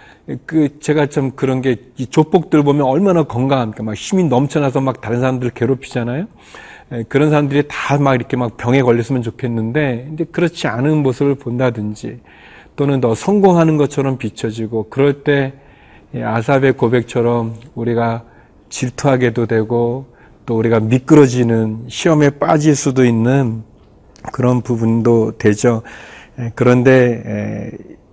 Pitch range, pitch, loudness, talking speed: 115-140 Hz, 125 Hz, -15 LUFS, 305 characters per minute